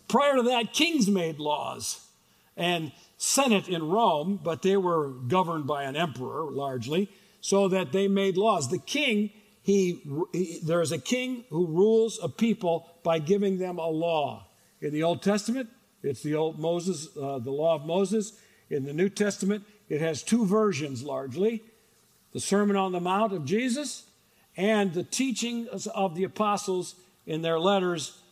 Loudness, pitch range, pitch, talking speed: -27 LUFS, 165-210 Hz, 190 Hz, 165 wpm